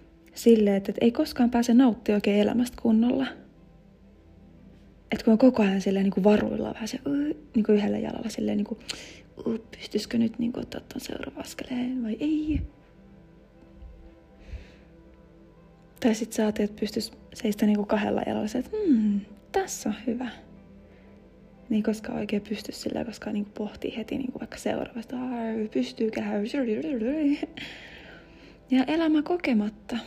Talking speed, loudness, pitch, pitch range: 145 wpm, -27 LUFS, 225 Hz, 210-255 Hz